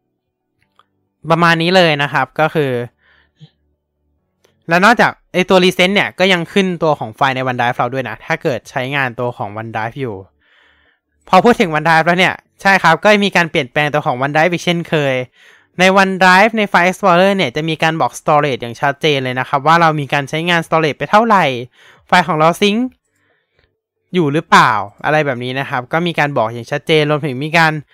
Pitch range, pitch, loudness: 130-175 Hz, 155 Hz, -13 LUFS